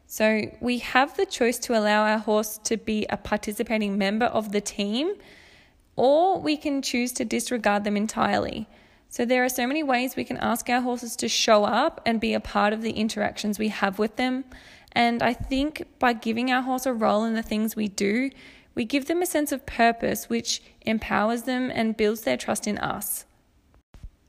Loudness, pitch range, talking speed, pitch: -25 LUFS, 215-255 Hz, 200 wpm, 230 Hz